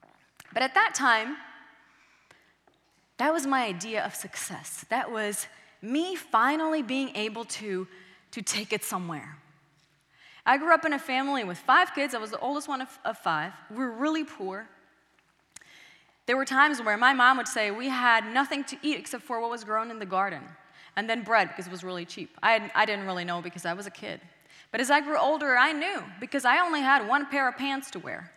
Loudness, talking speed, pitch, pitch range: -27 LUFS, 210 wpm, 235 Hz, 195-280 Hz